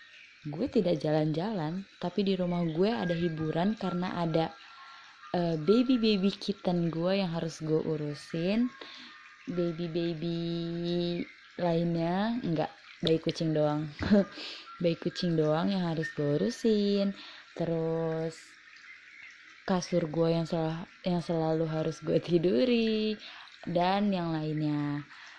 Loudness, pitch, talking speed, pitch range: -30 LUFS, 170 Hz, 105 wpm, 160-195 Hz